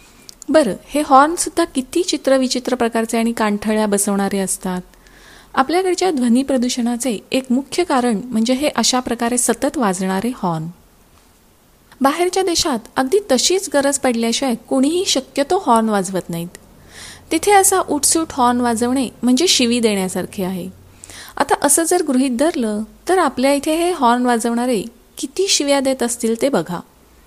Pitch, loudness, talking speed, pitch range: 255 Hz, -17 LUFS, 135 wpm, 225-295 Hz